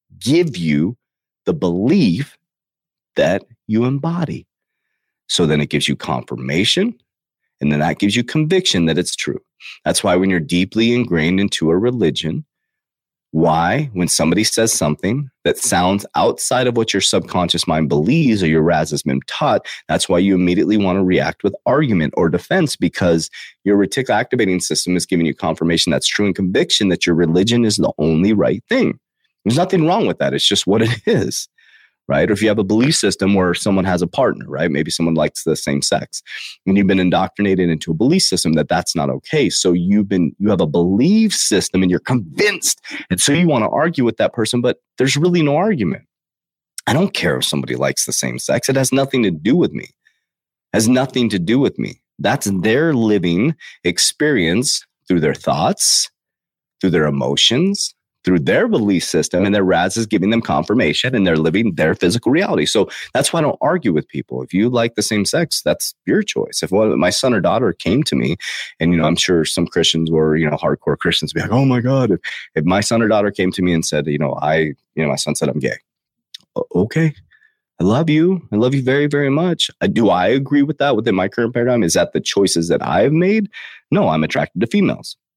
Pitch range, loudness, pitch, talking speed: 85-125 Hz, -16 LUFS, 95 Hz, 210 wpm